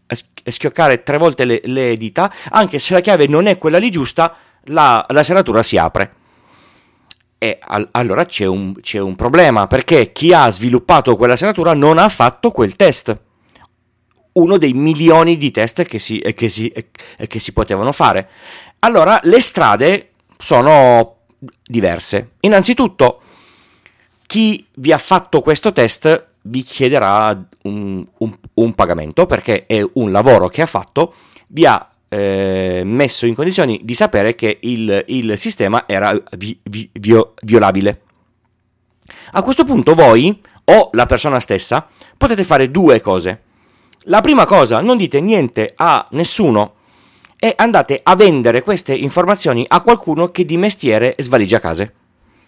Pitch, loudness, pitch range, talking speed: 125 Hz, -12 LUFS, 110-170 Hz, 145 wpm